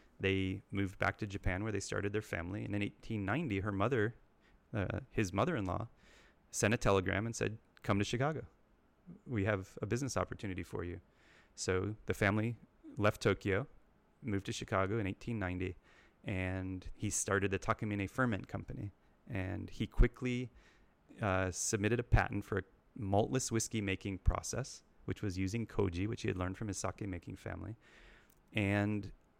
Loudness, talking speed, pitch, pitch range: -37 LUFS, 155 wpm, 100 Hz, 95-115 Hz